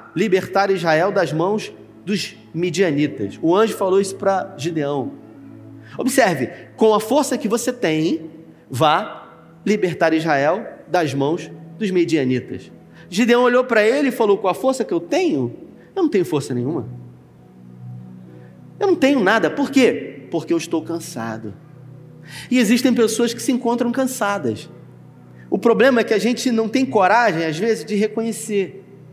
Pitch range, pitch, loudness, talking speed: 145-230 Hz, 185 Hz, -19 LUFS, 150 wpm